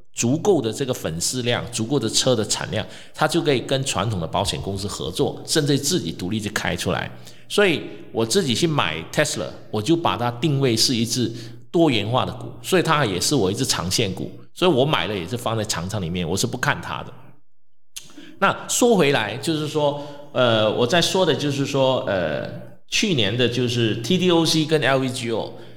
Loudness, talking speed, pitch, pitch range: -21 LUFS, 285 characters per minute, 125 Hz, 110-150 Hz